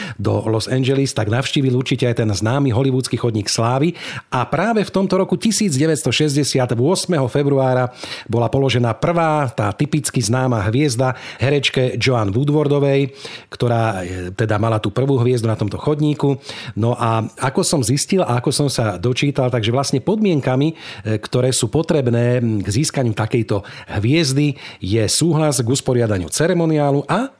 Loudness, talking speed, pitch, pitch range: -18 LUFS, 140 wpm, 130 Hz, 115-150 Hz